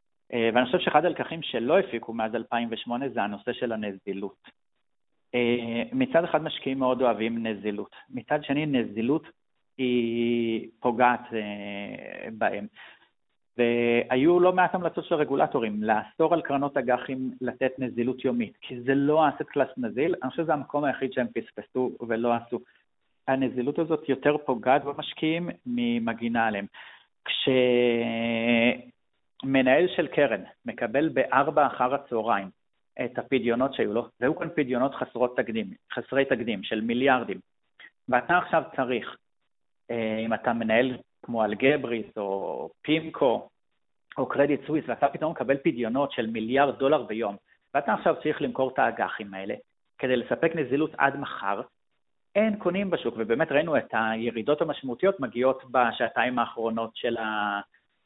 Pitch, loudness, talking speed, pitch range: 125 Hz, -27 LUFS, 130 wpm, 115-145 Hz